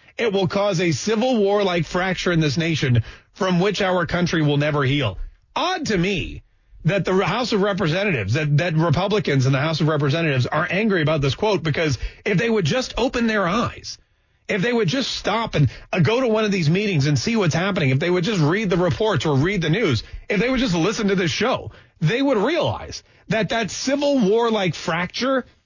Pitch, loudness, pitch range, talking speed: 180 Hz, -20 LUFS, 150-210 Hz, 215 wpm